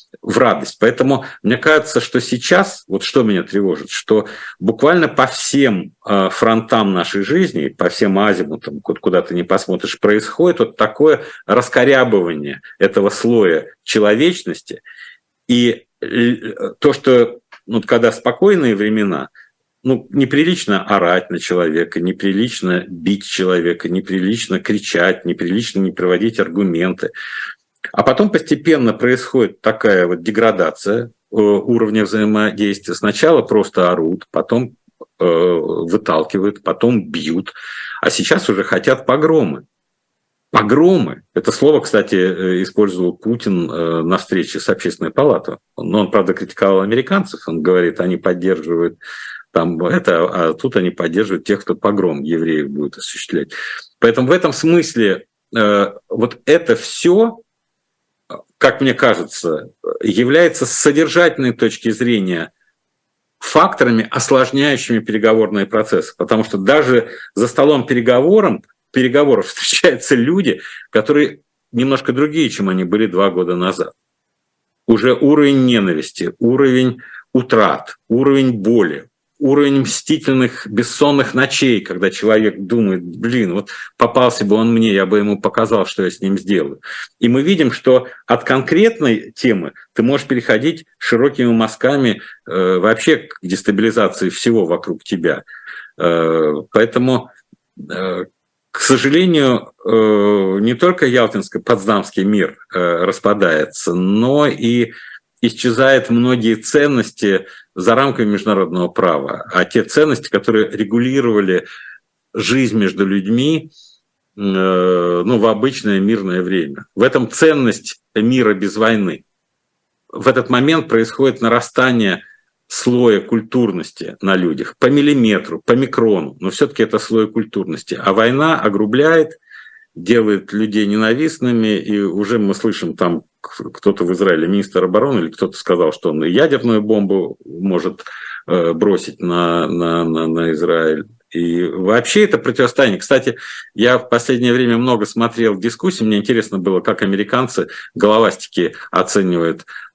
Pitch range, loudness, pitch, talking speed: 100-130 Hz, -15 LUFS, 115 Hz, 120 wpm